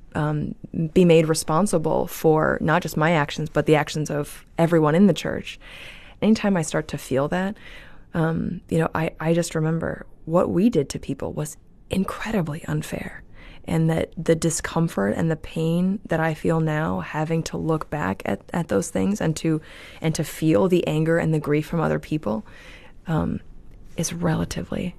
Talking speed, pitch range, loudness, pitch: 175 wpm, 155-170 Hz, -23 LUFS, 160 Hz